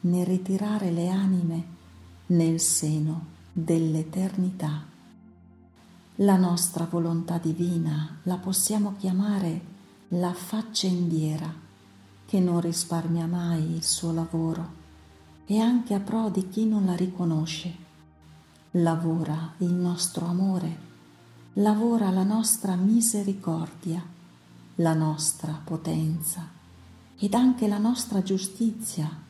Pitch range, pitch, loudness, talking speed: 160-190 Hz, 170 Hz, -26 LUFS, 100 wpm